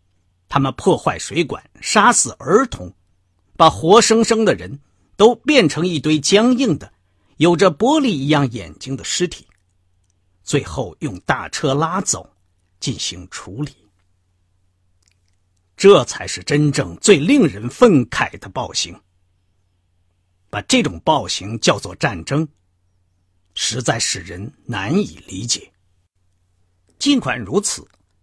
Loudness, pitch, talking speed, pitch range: -17 LUFS, 90 Hz, 170 characters per minute, 90-150 Hz